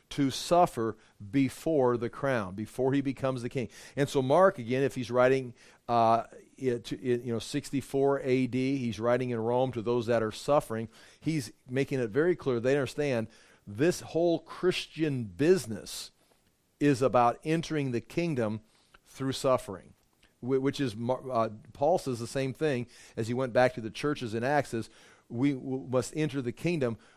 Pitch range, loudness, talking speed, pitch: 120-140 Hz, -30 LUFS, 165 wpm, 130 Hz